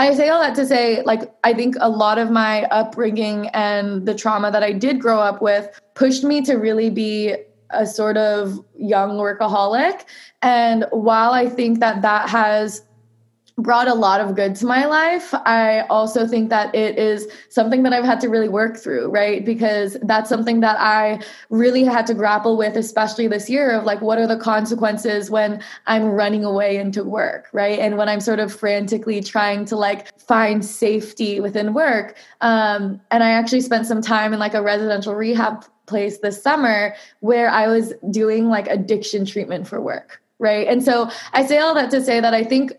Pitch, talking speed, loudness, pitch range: 220 Hz, 195 wpm, -18 LUFS, 210-230 Hz